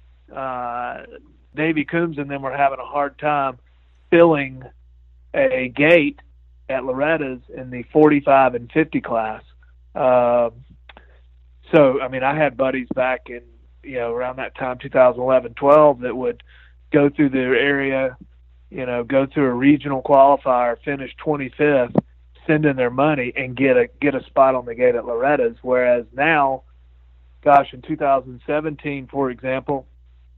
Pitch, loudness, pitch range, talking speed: 130 Hz, -19 LUFS, 110-140 Hz, 150 wpm